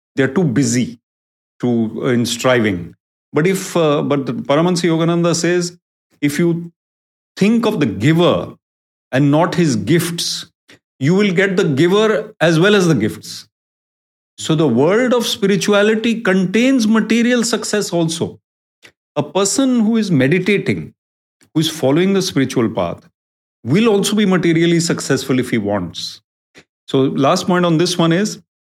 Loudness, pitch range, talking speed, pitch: -15 LUFS, 130-195 Hz, 145 wpm, 170 Hz